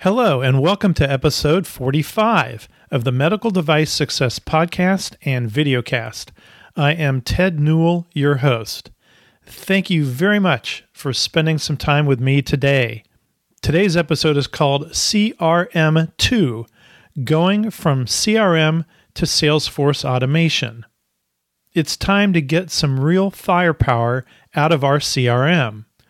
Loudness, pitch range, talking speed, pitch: -17 LUFS, 130-170 Hz, 125 wpm, 150 Hz